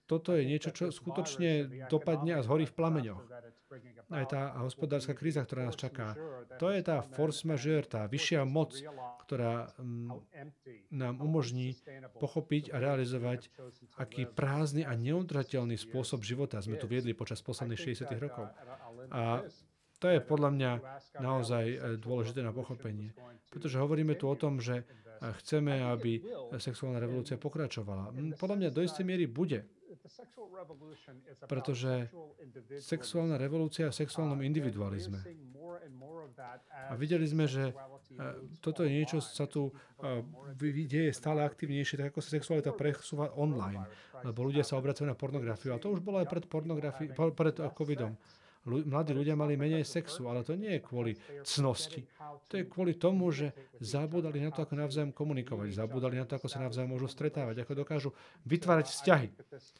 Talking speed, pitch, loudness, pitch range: 145 wpm, 140 Hz, -35 LUFS, 125-155 Hz